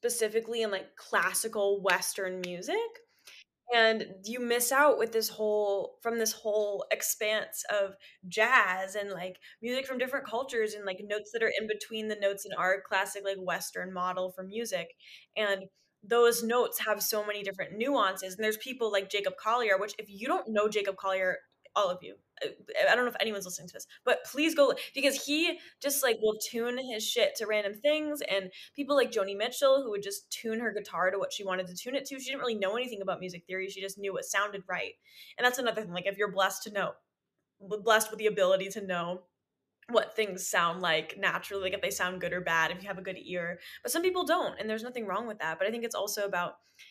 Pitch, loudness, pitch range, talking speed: 210 Hz, -31 LUFS, 190-240 Hz, 220 wpm